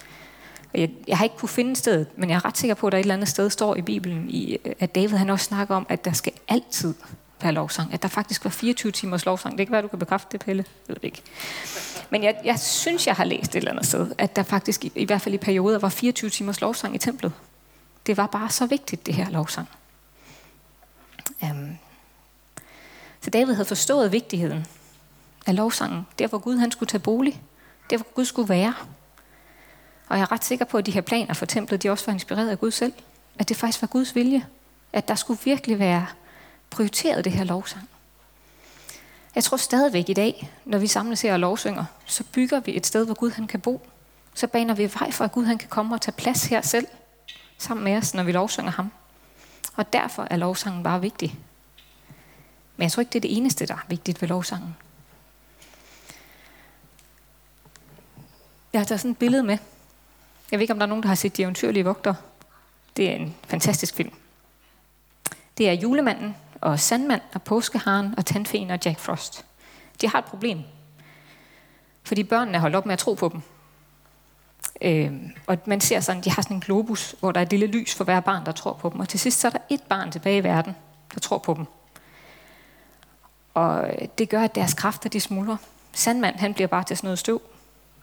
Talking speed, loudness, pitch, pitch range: 210 wpm, -24 LUFS, 200 Hz, 180-230 Hz